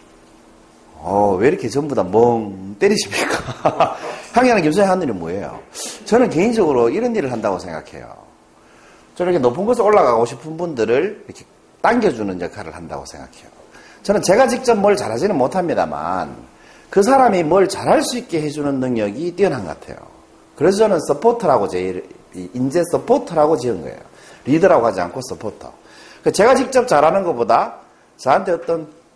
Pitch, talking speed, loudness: 160 Hz, 340 characters per minute, -17 LUFS